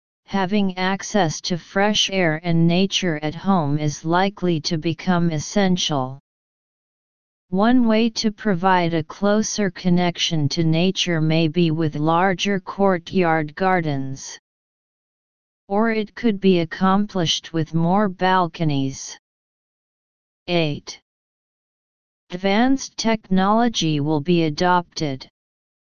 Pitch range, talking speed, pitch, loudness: 160-195 Hz, 100 wpm, 180 Hz, -20 LUFS